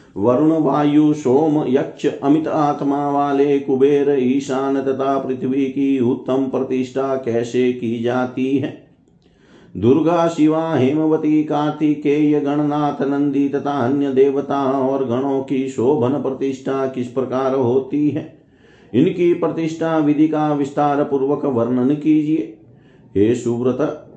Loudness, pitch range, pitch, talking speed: -18 LUFS, 130-150 Hz, 140 Hz, 115 wpm